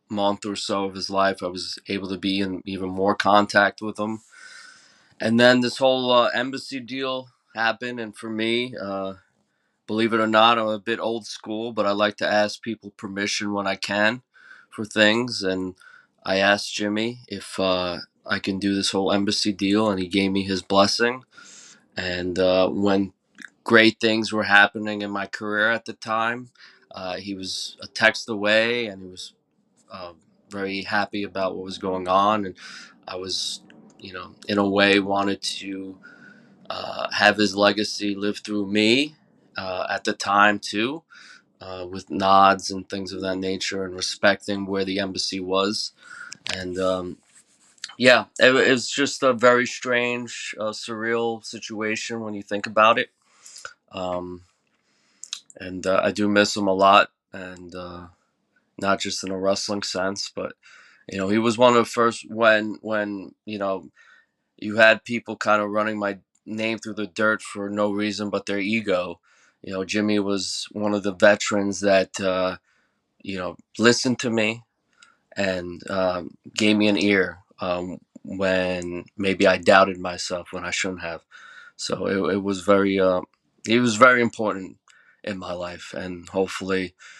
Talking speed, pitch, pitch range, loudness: 170 wpm, 100 Hz, 95-110 Hz, -22 LUFS